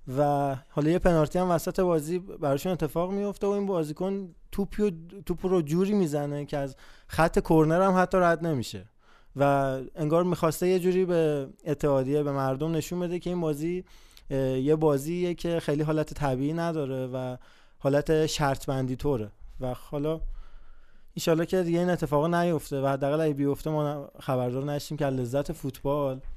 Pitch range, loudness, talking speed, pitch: 140-175 Hz, -27 LUFS, 155 wpm, 155 Hz